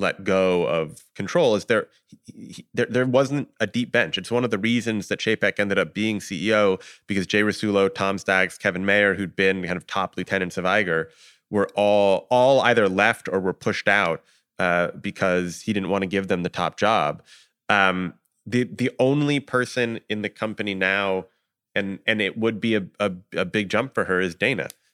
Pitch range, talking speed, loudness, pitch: 95-110 Hz, 200 wpm, -22 LUFS, 100 Hz